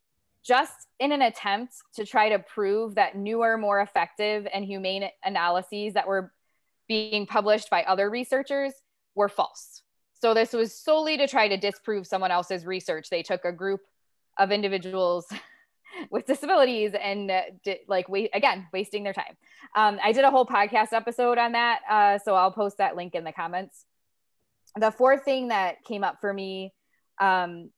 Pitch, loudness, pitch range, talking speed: 205 Hz, -25 LUFS, 190-235 Hz, 170 wpm